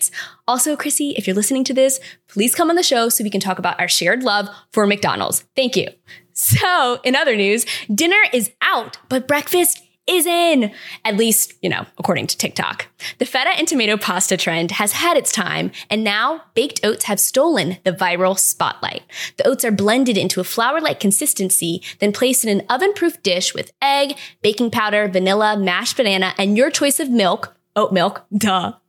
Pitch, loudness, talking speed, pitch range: 220 Hz, -17 LUFS, 185 wpm, 195-270 Hz